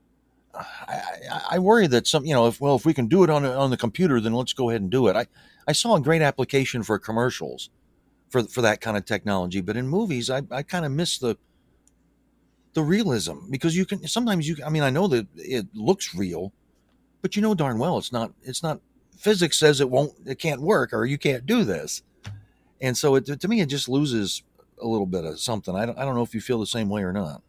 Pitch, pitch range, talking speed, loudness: 135 Hz, 115-165 Hz, 240 wpm, -24 LUFS